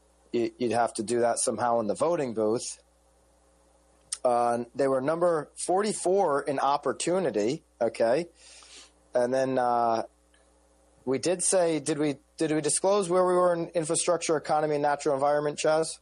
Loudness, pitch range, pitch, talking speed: -27 LUFS, 115-160 Hz, 135 Hz, 145 wpm